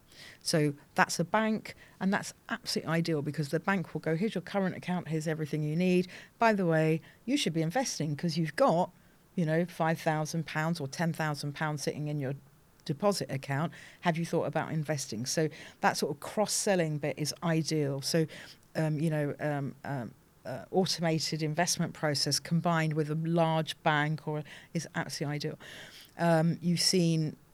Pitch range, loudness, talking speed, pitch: 155-175 Hz, -31 LUFS, 175 wpm, 160 Hz